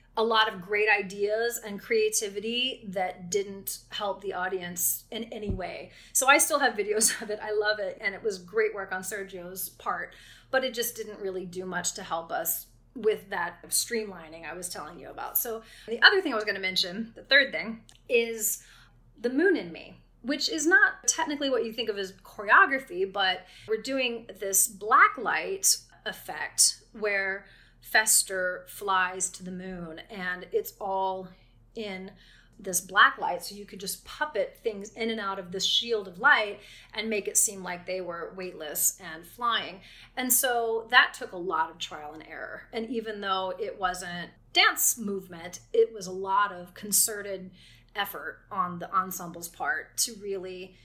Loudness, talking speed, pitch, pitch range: -27 LUFS, 180 wpm, 210 Hz, 185-235 Hz